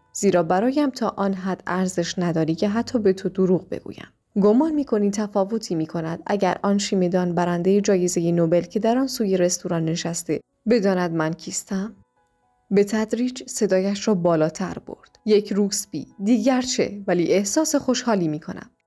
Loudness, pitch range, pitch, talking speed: -22 LUFS, 175-220 Hz, 195 Hz, 155 wpm